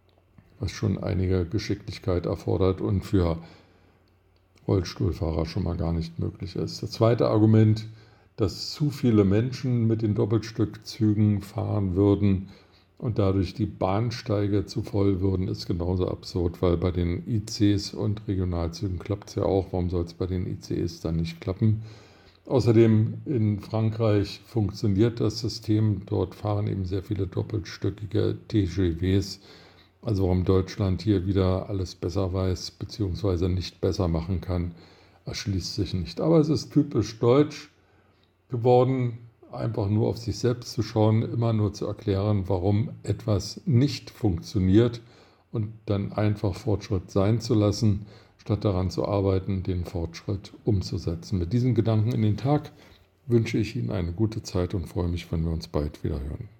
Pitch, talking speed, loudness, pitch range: 100 Hz, 150 wpm, -26 LUFS, 95-110 Hz